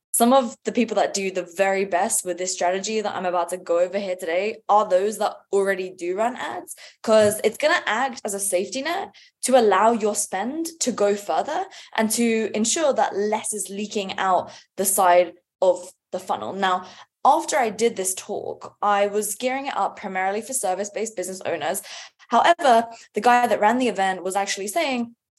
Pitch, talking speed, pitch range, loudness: 205 Hz, 195 wpm, 190-235 Hz, -22 LUFS